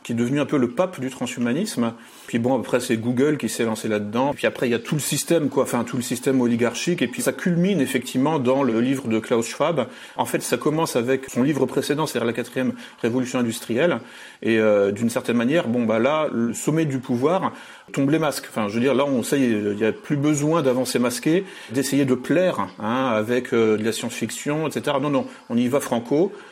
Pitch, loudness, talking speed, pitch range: 125 Hz, -22 LUFS, 230 wpm, 115-145 Hz